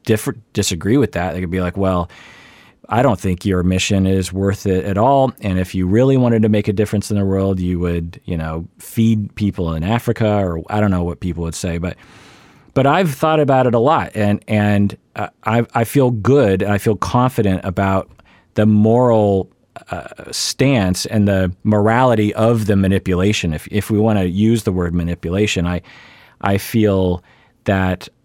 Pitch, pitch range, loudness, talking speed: 100 Hz, 95-115 Hz, -17 LUFS, 190 wpm